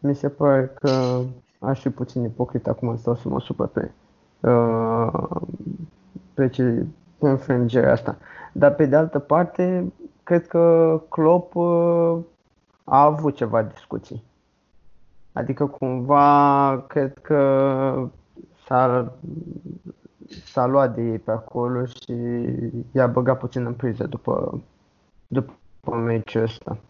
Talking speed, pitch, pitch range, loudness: 115 wpm, 130 Hz, 120-150 Hz, -21 LUFS